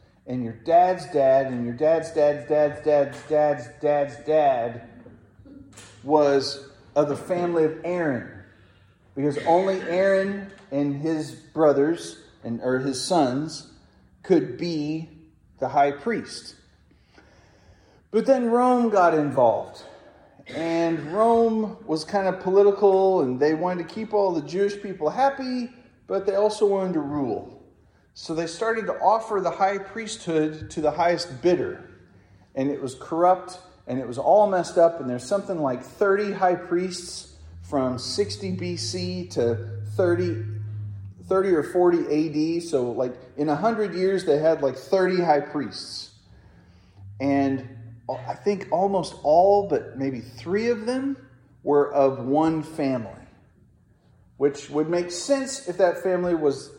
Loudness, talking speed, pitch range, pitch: -23 LUFS, 145 wpm, 130-185 Hz, 150 Hz